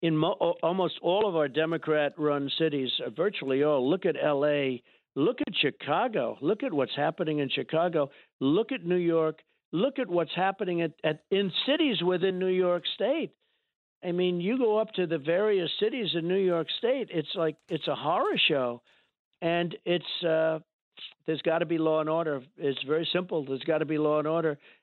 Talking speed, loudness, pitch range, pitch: 185 wpm, -28 LUFS, 150-180 Hz, 165 Hz